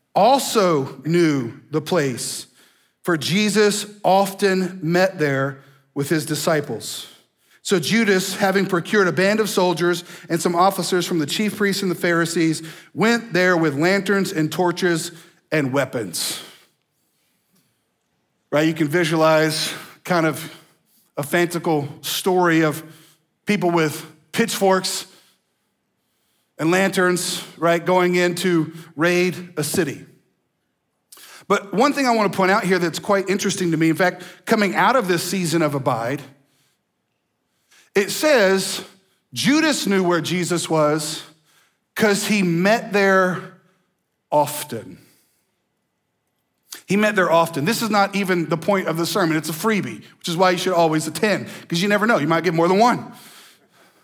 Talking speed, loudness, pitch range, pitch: 140 wpm, -19 LUFS, 160-195 Hz, 175 Hz